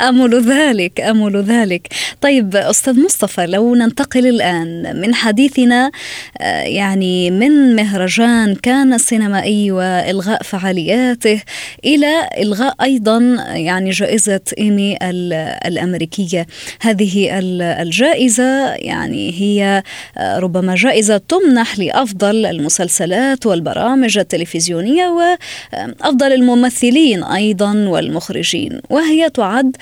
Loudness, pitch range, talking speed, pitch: -13 LUFS, 190-255 Hz, 85 wpm, 215 Hz